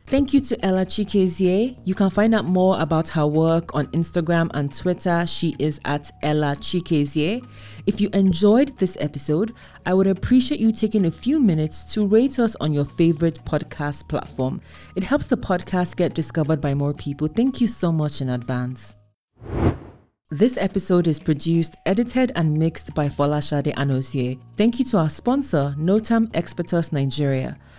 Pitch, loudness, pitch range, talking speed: 170 Hz, -21 LUFS, 150-205 Hz, 165 wpm